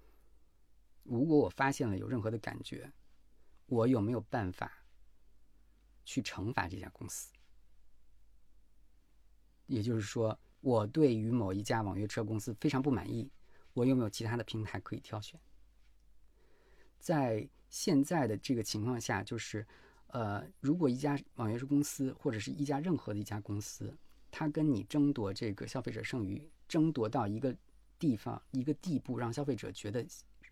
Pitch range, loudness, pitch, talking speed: 95-135 Hz, -36 LUFS, 115 Hz, 235 characters per minute